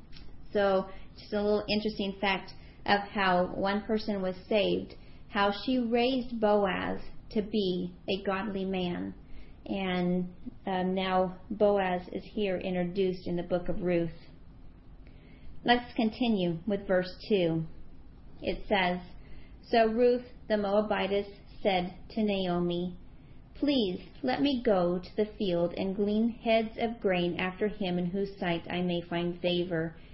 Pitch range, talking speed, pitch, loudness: 180-215 Hz, 135 wpm, 195 Hz, -30 LUFS